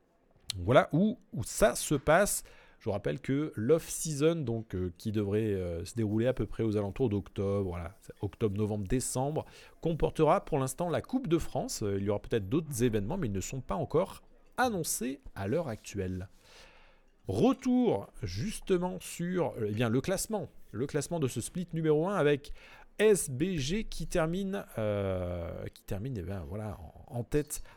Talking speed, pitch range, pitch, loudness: 165 wpm, 105-160 Hz, 125 Hz, -32 LUFS